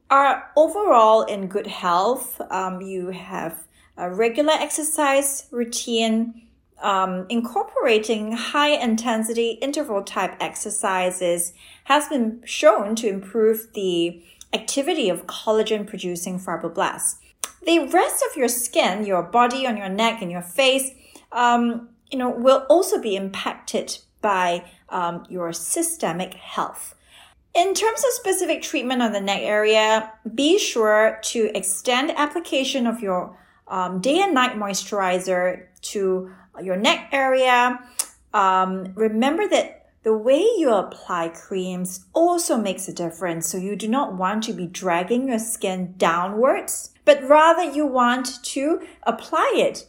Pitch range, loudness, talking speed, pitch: 190-275 Hz, -21 LUFS, 130 wpm, 225 Hz